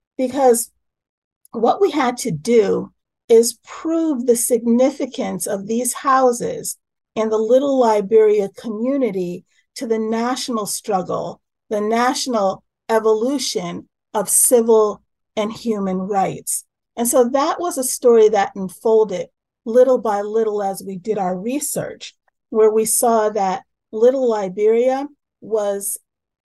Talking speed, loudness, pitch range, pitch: 120 wpm, -18 LUFS, 210-255 Hz, 225 Hz